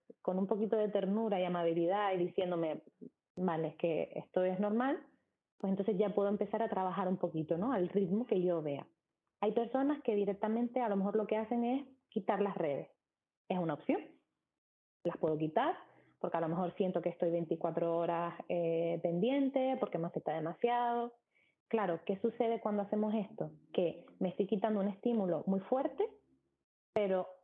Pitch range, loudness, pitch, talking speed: 175-225 Hz, -36 LUFS, 200 Hz, 175 wpm